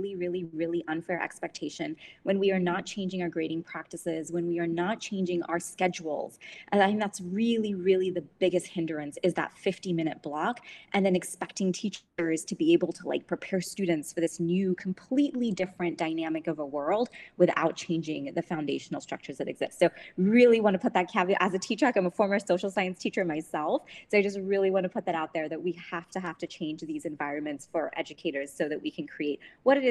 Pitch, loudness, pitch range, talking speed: 180 Hz, -29 LUFS, 165-195 Hz, 215 wpm